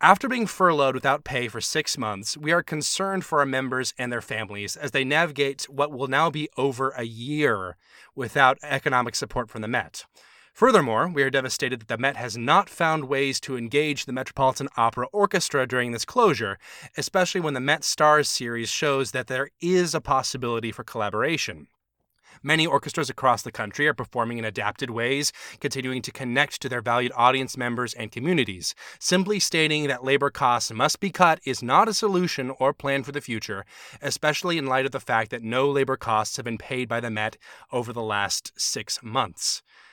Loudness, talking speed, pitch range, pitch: -24 LUFS, 190 wpm, 120-150 Hz, 135 Hz